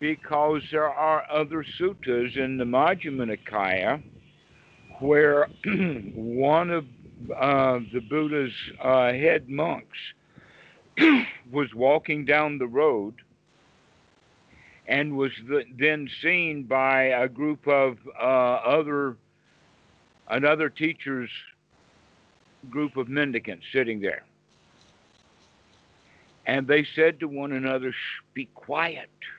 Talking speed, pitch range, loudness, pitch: 100 wpm, 130-155 Hz, -25 LUFS, 140 Hz